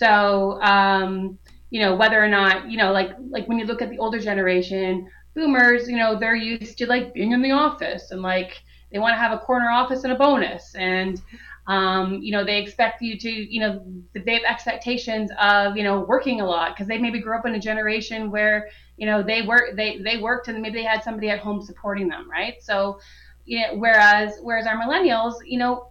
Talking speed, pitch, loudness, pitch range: 220 wpm, 220 Hz, -21 LUFS, 200-235 Hz